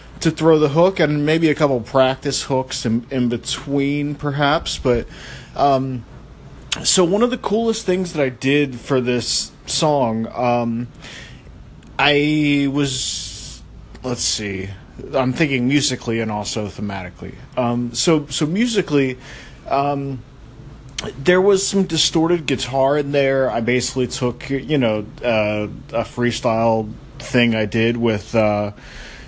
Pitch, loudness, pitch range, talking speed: 130 Hz, -19 LUFS, 120-145 Hz, 130 wpm